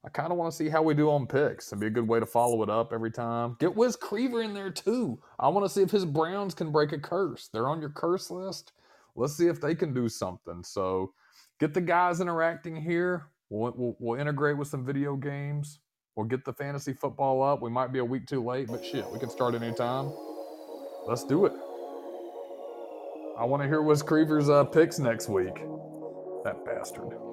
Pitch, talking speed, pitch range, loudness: 145 Hz, 215 wpm, 120-165 Hz, -29 LUFS